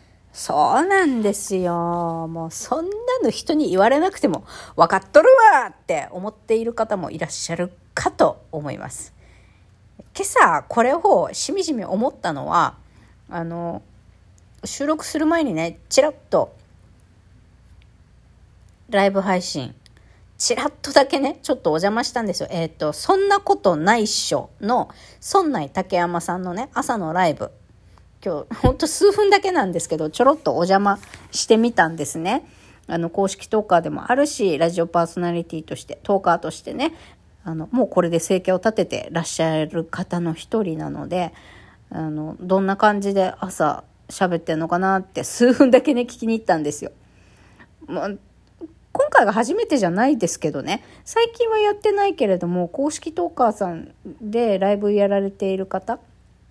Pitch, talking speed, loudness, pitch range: 195 Hz, 315 characters per minute, -20 LUFS, 170-280 Hz